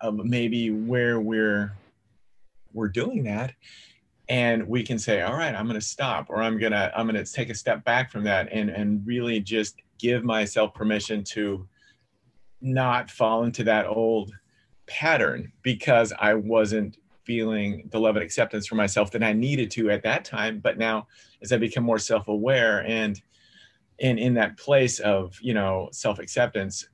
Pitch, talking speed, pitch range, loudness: 110 Hz, 165 wpm, 105-120 Hz, -25 LUFS